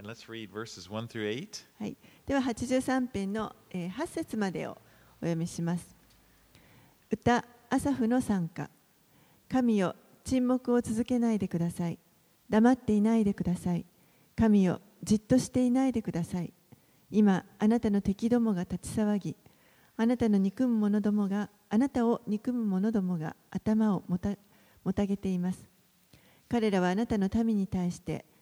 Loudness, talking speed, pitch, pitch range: -30 LUFS, 225 characters per minute, 205 Hz, 175-230 Hz